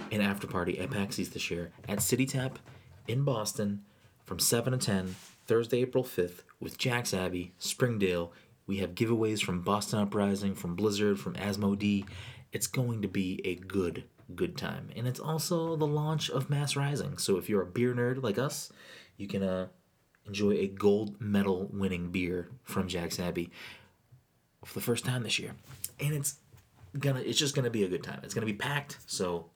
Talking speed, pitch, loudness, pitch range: 185 wpm, 105 Hz, -32 LUFS, 95-125 Hz